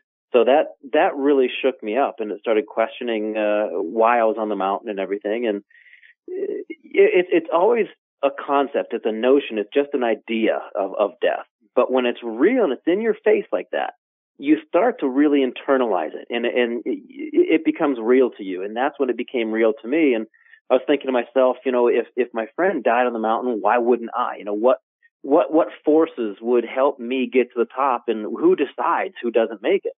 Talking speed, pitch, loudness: 220 wpm, 130 Hz, -21 LUFS